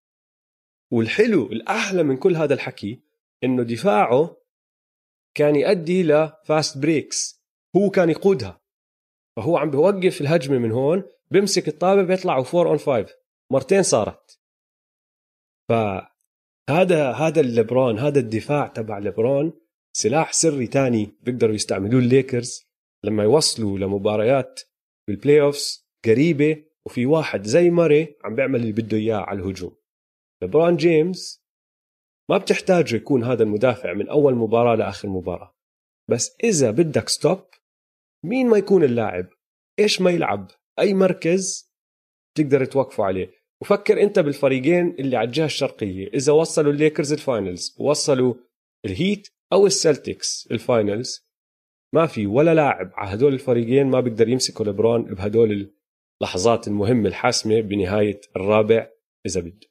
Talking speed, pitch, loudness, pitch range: 125 wpm, 140 Hz, -20 LUFS, 110-170 Hz